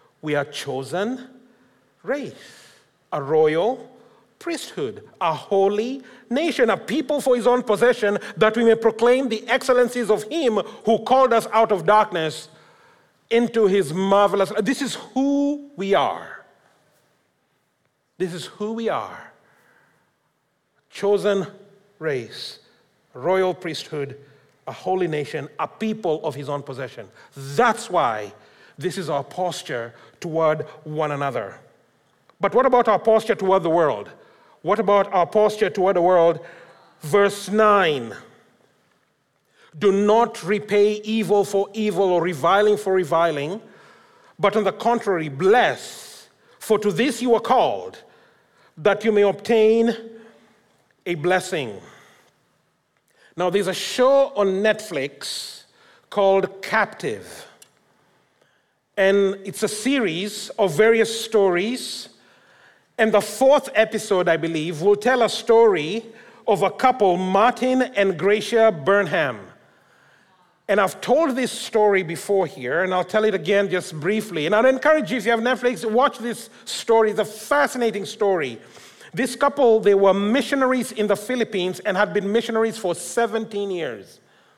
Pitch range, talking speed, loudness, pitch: 185-230 Hz, 130 wpm, -21 LUFS, 205 Hz